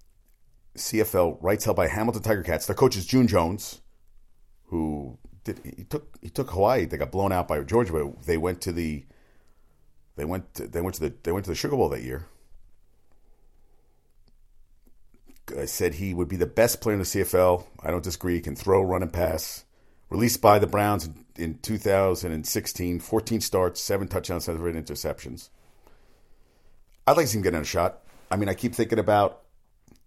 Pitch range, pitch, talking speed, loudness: 80-105 Hz, 90 Hz, 185 wpm, -26 LUFS